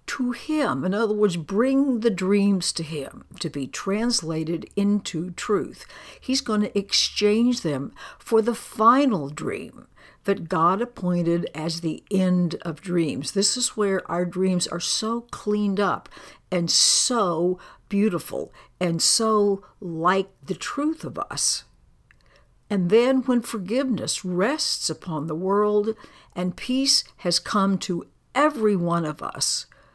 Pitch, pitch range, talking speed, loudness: 200 Hz, 175-225 Hz, 135 wpm, -23 LUFS